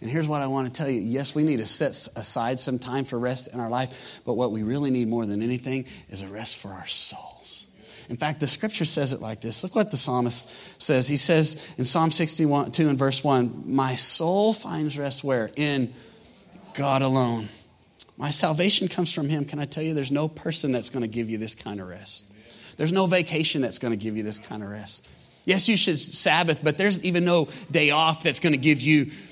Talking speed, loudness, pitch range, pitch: 230 wpm, -24 LUFS, 120-155 Hz, 140 Hz